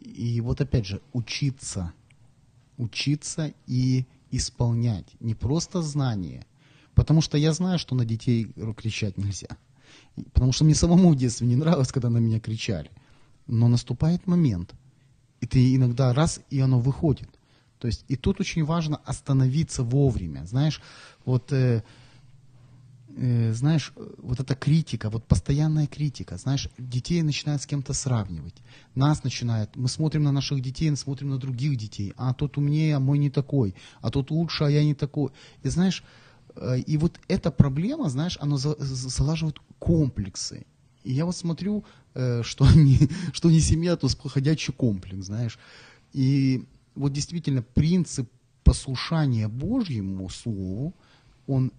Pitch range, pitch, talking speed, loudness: 120-150 Hz, 130 Hz, 145 wpm, -25 LUFS